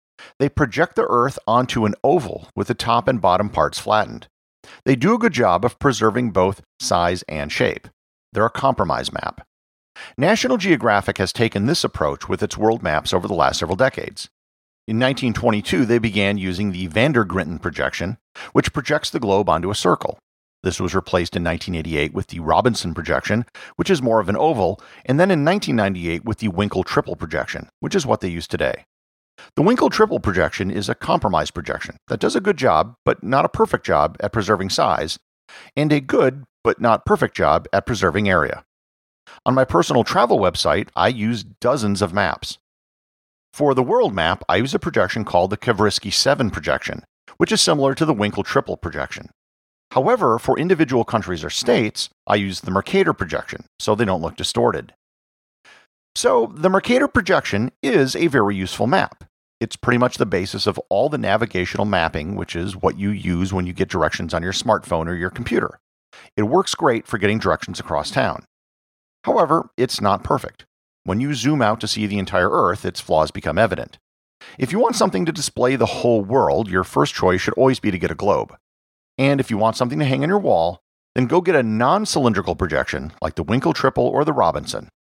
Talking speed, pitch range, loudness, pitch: 190 wpm, 90-125 Hz, -19 LUFS, 105 Hz